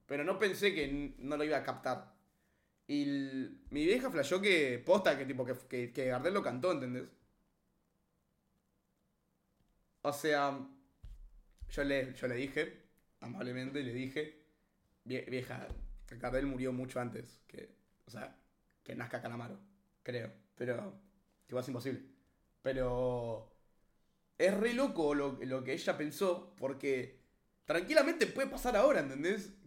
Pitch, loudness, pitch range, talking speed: 140 Hz, -36 LUFS, 125-190 Hz, 135 wpm